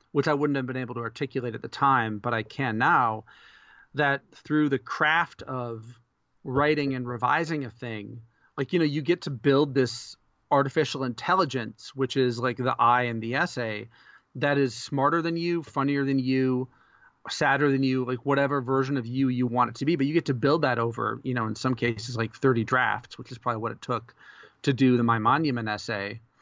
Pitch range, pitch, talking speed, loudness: 120-140 Hz, 130 Hz, 205 wpm, -26 LUFS